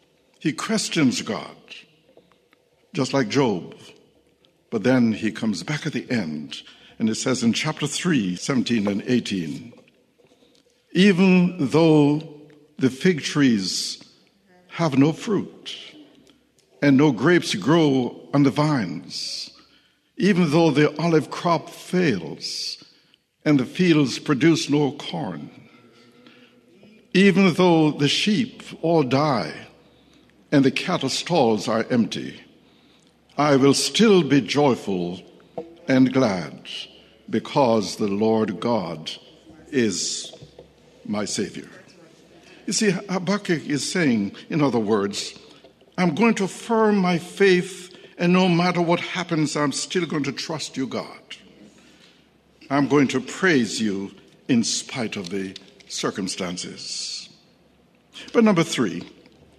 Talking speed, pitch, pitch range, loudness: 115 wpm, 150 Hz, 130-180 Hz, -21 LUFS